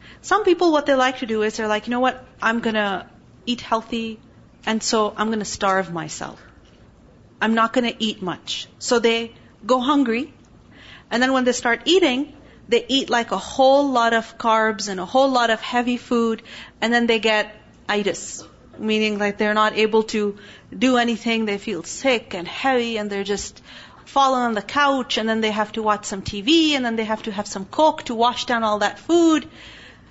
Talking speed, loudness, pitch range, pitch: 200 wpm, -20 LUFS, 215-255 Hz, 225 Hz